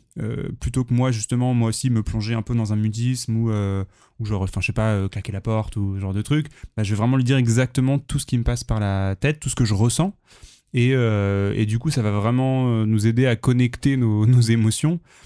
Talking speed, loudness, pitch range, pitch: 260 wpm, -21 LUFS, 105-130 Hz, 115 Hz